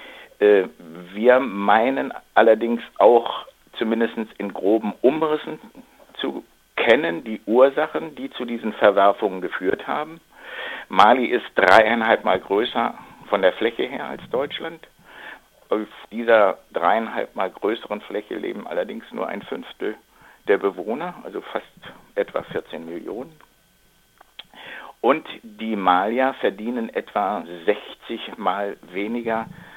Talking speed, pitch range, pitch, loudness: 110 wpm, 110-165 Hz, 120 Hz, -21 LUFS